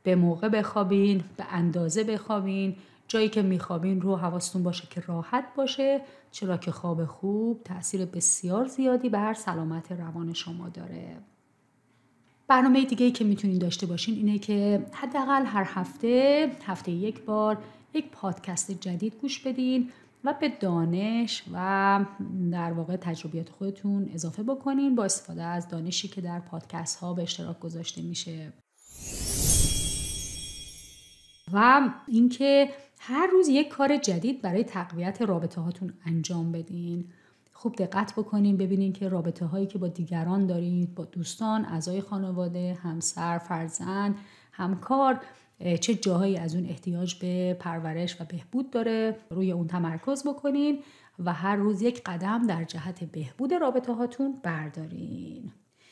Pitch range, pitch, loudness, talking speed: 170-225 Hz, 190 Hz, -28 LUFS, 135 wpm